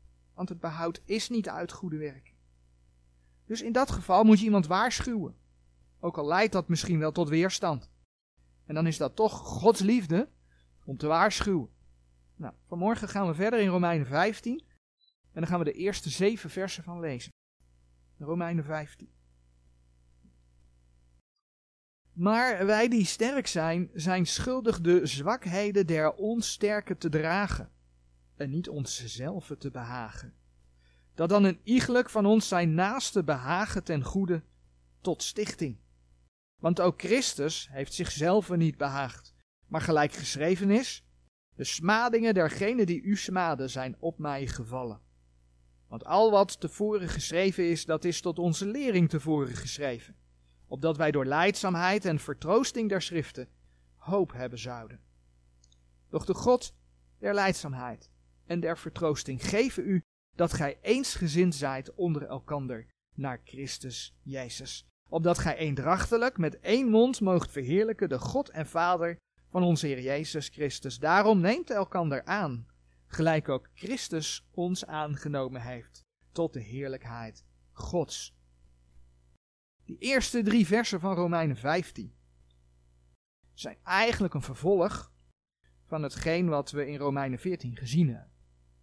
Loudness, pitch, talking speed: -29 LUFS, 155 Hz, 135 wpm